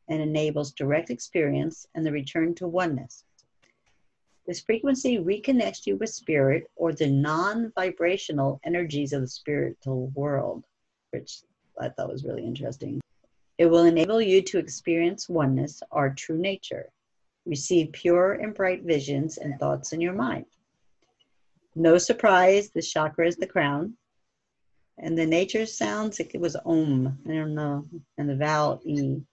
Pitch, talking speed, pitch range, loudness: 165 Hz, 145 wpm, 145-185 Hz, -26 LUFS